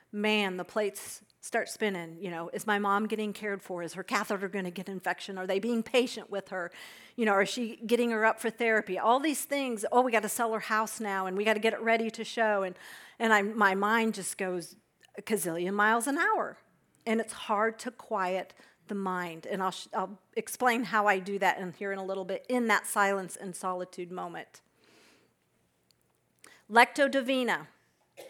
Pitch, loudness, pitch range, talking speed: 210 Hz, -30 LUFS, 190-225 Hz, 205 wpm